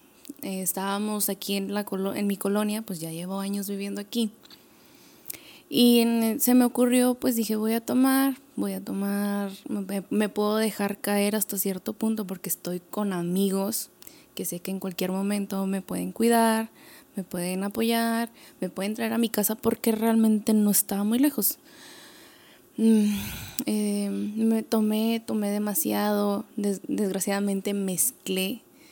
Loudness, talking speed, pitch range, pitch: -26 LUFS, 150 wpm, 200-230 Hz, 210 Hz